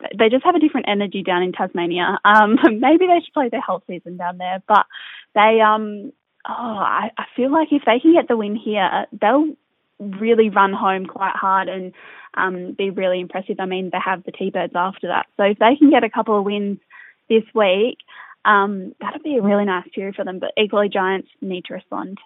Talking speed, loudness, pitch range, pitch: 215 wpm, -18 LUFS, 190-225 Hz, 205 Hz